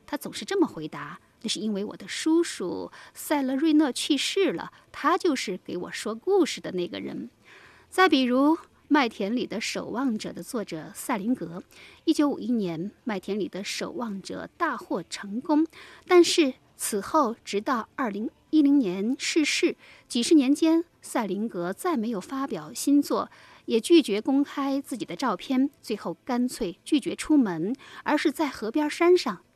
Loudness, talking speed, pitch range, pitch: -26 LUFS, 240 characters per minute, 210-310 Hz, 265 Hz